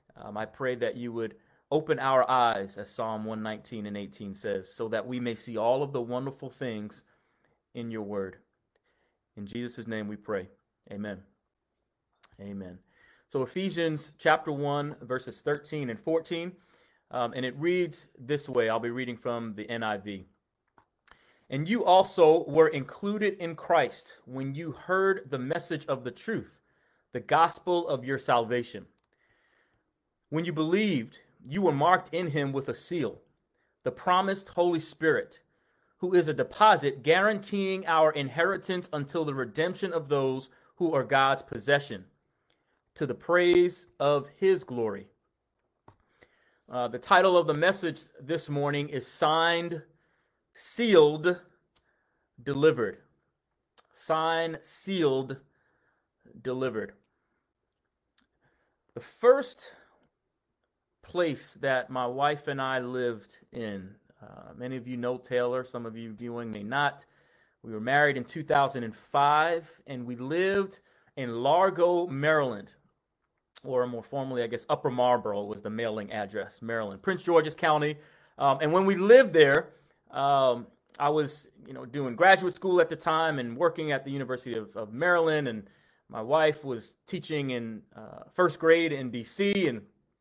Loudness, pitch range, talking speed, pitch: -28 LUFS, 120-170 Hz, 140 wpm, 145 Hz